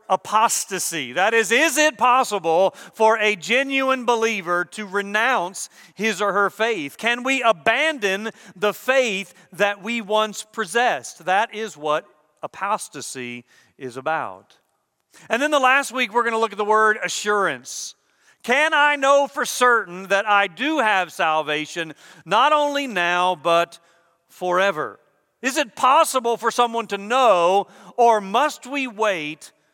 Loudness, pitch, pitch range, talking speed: -20 LUFS, 215 Hz, 180-245 Hz, 140 wpm